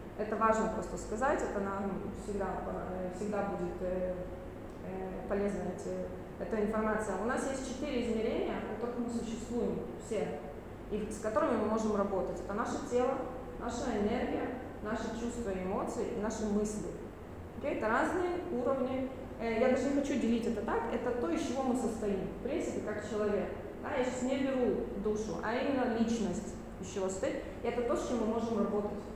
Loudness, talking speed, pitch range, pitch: -35 LUFS, 155 wpm, 200-245 Hz, 220 Hz